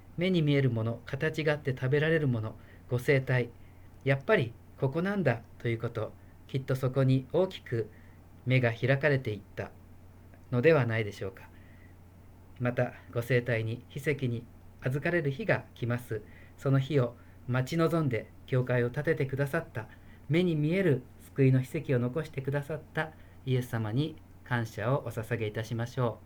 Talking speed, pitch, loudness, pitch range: 320 characters per minute, 120 Hz, -31 LUFS, 105-140 Hz